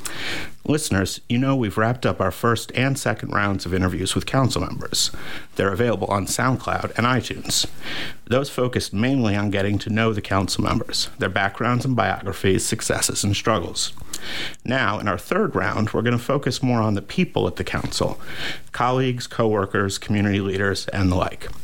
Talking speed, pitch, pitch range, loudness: 170 wpm, 110 Hz, 100-125 Hz, -22 LUFS